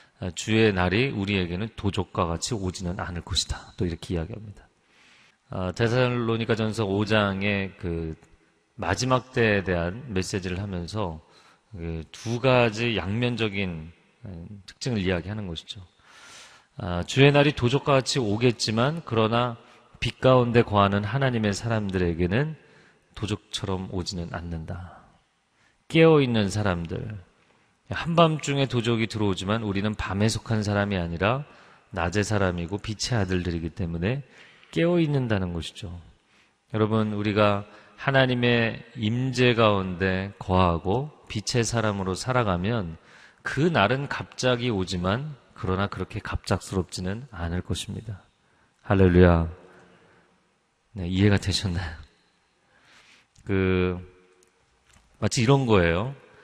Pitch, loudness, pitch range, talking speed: 105 Hz, -25 LUFS, 90-120 Hz, 270 characters per minute